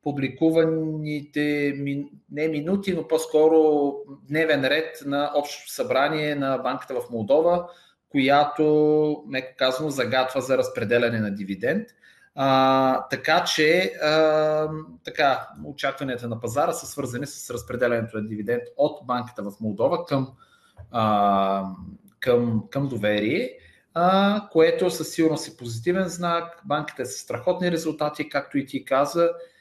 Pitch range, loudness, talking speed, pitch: 125-160 Hz, -23 LUFS, 125 wpm, 145 Hz